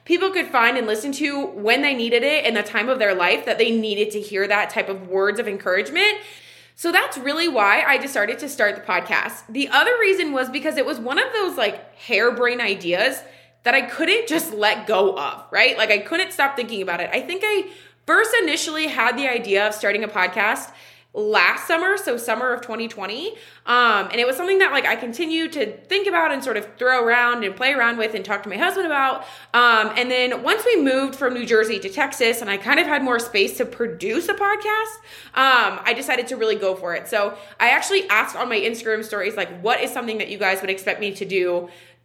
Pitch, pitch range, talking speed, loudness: 240 Hz, 210-315 Hz, 230 wpm, -20 LUFS